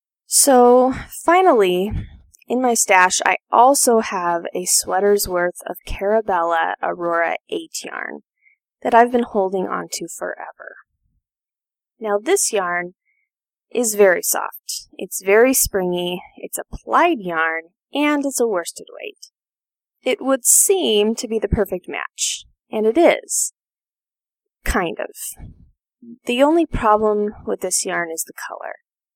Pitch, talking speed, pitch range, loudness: 220 Hz, 125 wpm, 185-275 Hz, -18 LUFS